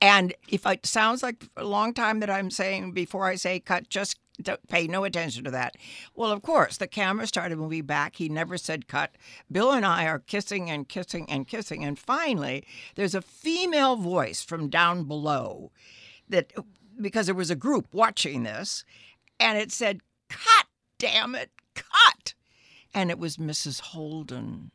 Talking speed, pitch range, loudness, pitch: 175 wpm, 155-210 Hz, -26 LUFS, 185 Hz